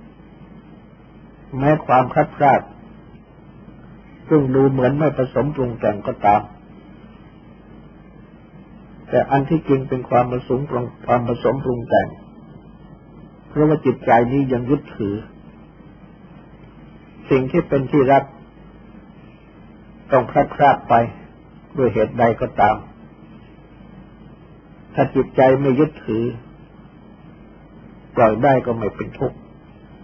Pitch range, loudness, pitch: 120-140 Hz, -18 LUFS, 130 Hz